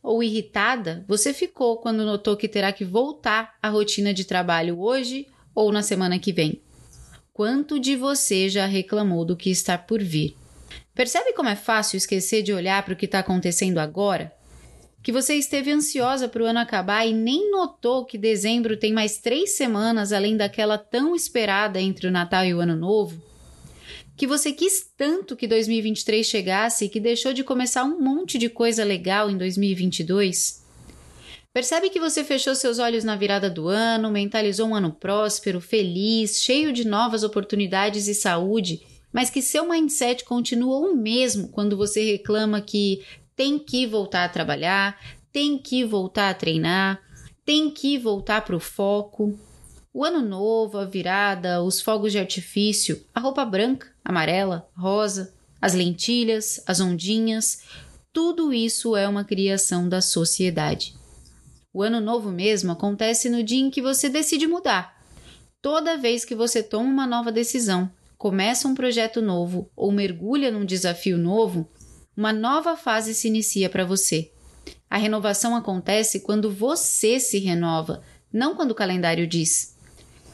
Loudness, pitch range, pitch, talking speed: -23 LUFS, 190-245 Hz, 215 Hz, 160 wpm